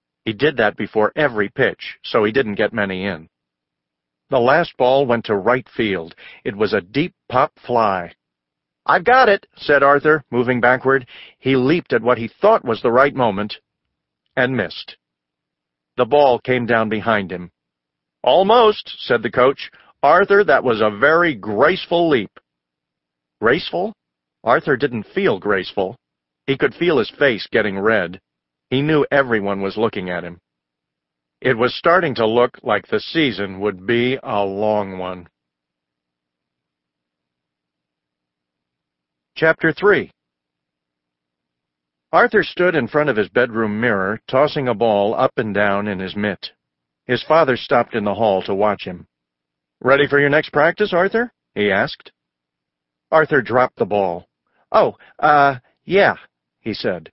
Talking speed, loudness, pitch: 145 wpm, -17 LUFS, 100 Hz